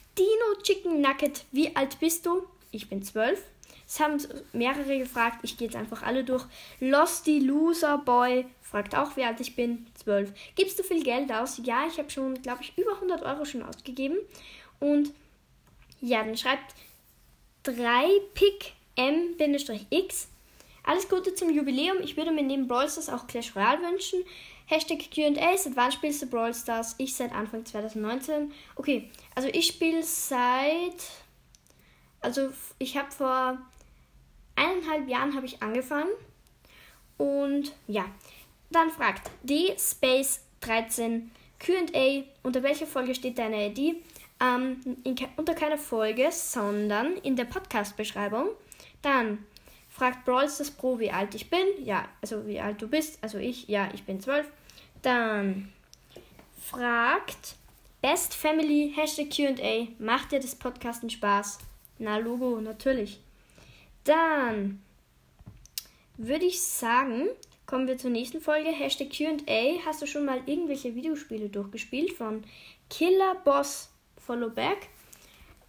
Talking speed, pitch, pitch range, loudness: 135 wpm, 270 Hz, 235-310 Hz, -28 LUFS